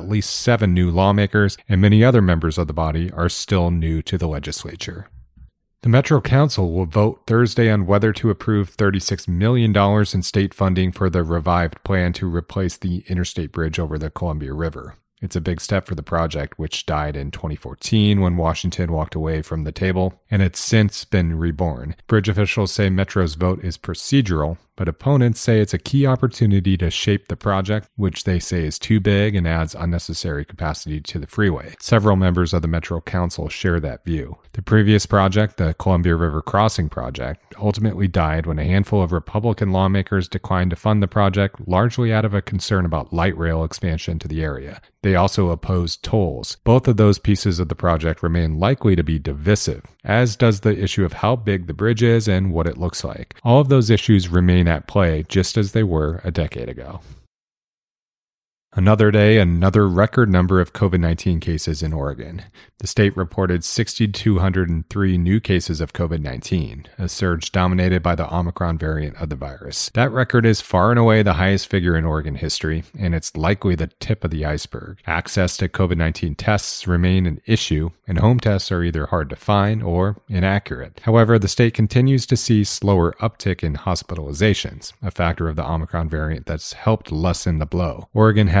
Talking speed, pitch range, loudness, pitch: 190 wpm, 85-105 Hz, -19 LUFS, 95 Hz